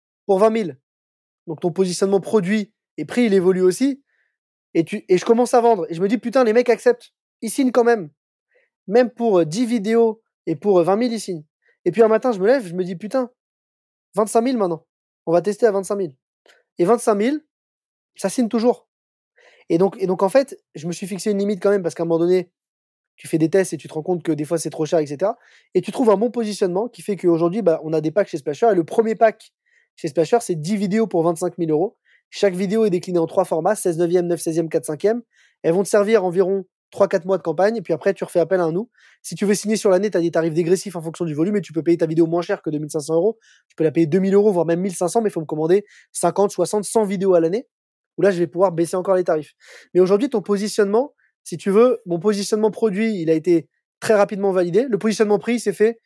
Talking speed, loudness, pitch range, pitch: 255 wpm, -20 LUFS, 170-220 Hz, 195 Hz